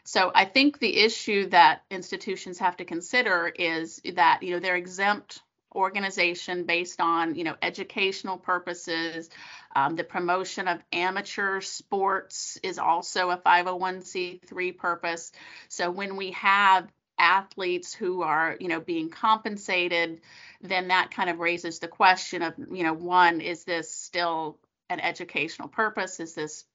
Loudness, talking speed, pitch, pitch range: -26 LUFS, 145 wpm, 180 Hz, 175-195 Hz